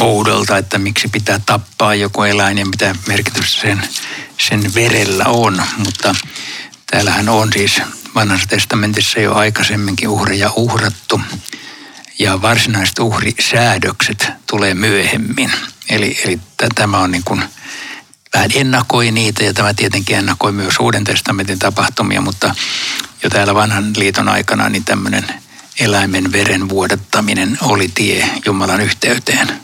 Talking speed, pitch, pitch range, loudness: 125 wpm, 105 Hz, 100-110 Hz, -13 LUFS